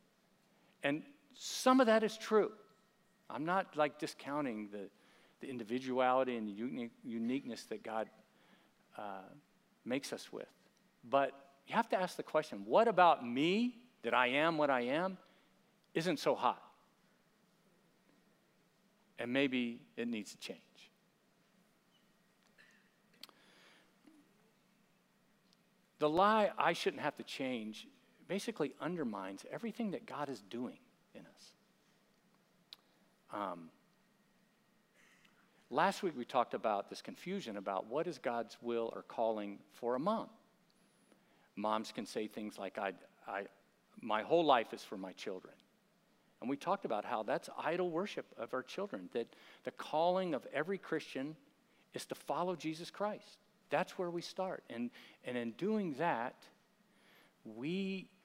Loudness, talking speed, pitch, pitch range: -38 LUFS, 130 wpm, 195 Hz, 140-215 Hz